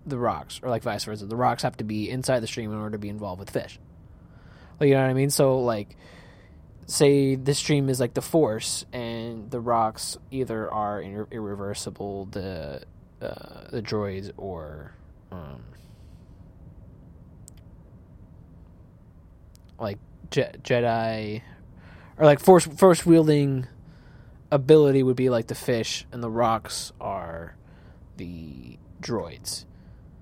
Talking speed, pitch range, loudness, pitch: 135 wpm, 95-130 Hz, -24 LUFS, 110 Hz